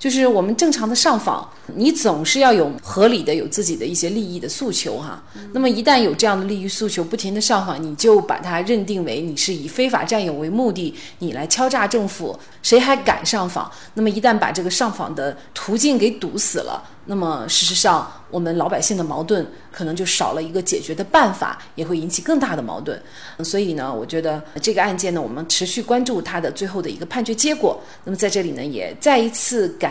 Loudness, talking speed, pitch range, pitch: -18 LUFS, 330 characters per minute, 170-230 Hz, 195 Hz